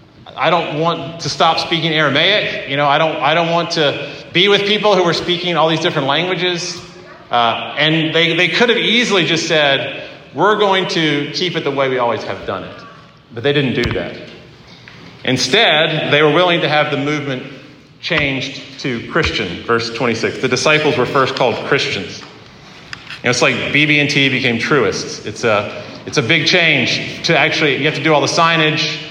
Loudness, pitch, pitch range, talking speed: -14 LUFS, 155 Hz, 140-170 Hz, 190 wpm